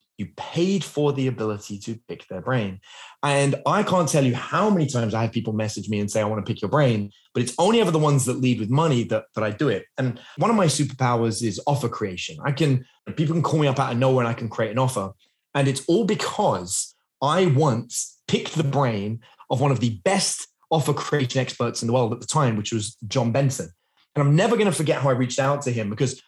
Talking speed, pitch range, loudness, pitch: 250 wpm, 115-150 Hz, -23 LUFS, 130 Hz